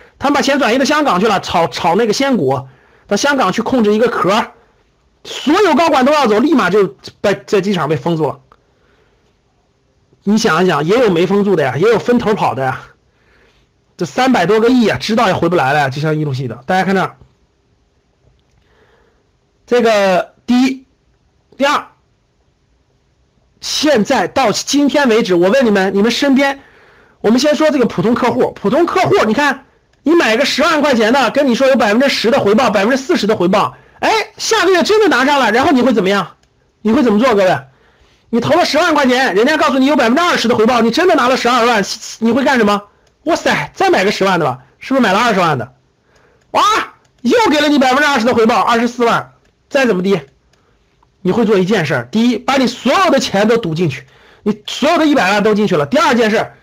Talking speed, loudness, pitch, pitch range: 295 characters per minute, -13 LUFS, 235 Hz, 205-280 Hz